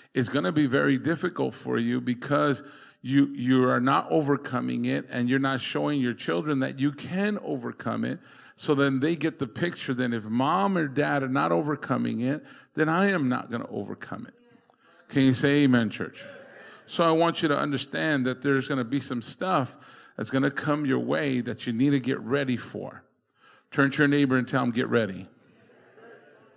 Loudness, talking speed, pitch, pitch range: -26 LUFS, 200 wpm, 140 Hz, 125-150 Hz